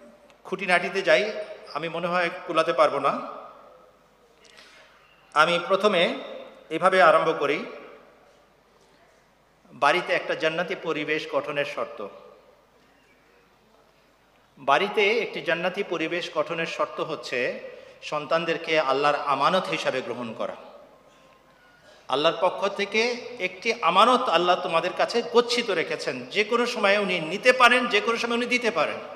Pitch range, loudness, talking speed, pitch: 165-230 Hz, -24 LUFS, 115 wpm, 185 Hz